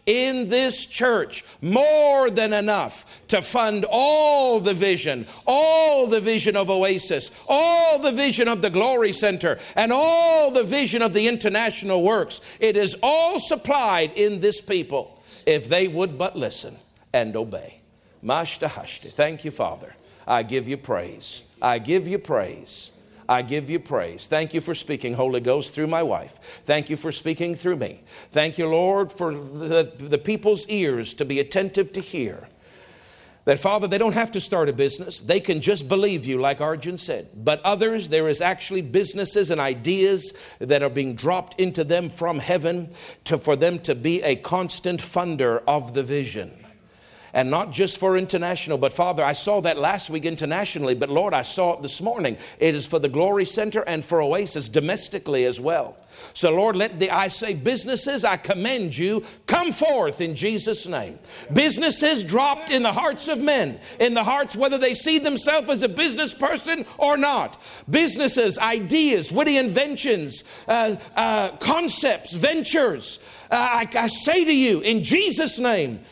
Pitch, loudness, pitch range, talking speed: 200 Hz, -22 LUFS, 165-250 Hz, 170 wpm